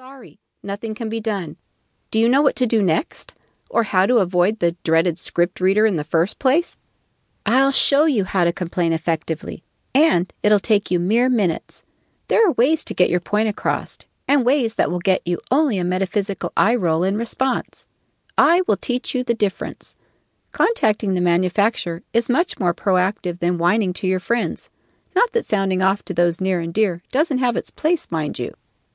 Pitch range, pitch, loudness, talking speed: 175-240 Hz, 200 Hz, -20 LUFS, 190 wpm